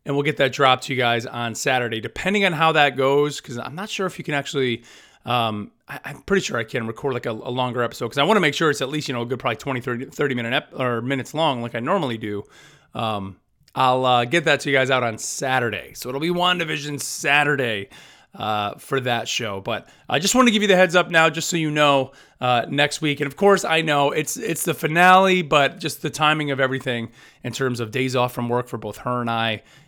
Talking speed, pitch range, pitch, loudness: 250 wpm, 120-155 Hz, 135 Hz, -21 LUFS